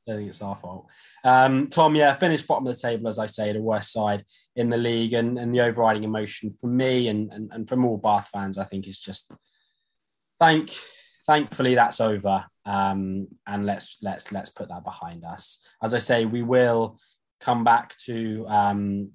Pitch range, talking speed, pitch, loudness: 100-125 Hz, 195 wpm, 110 Hz, -24 LUFS